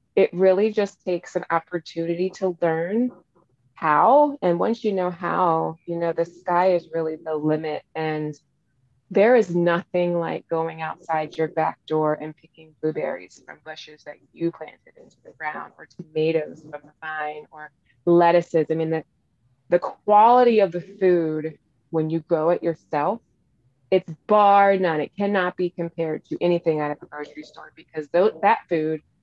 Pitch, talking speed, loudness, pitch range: 165 Hz, 165 wpm, -22 LUFS, 155-180 Hz